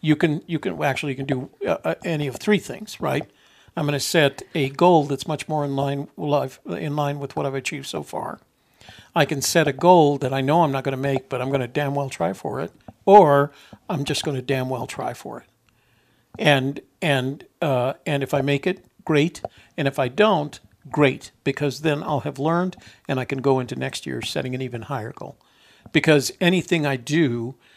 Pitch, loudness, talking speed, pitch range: 140 Hz, -22 LUFS, 215 wpm, 135-155 Hz